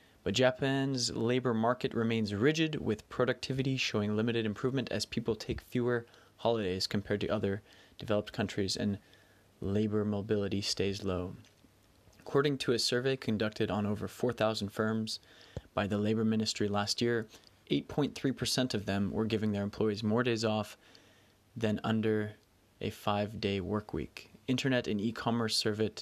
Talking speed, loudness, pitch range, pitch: 145 wpm, -33 LUFS, 105-120 Hz, 110 Hz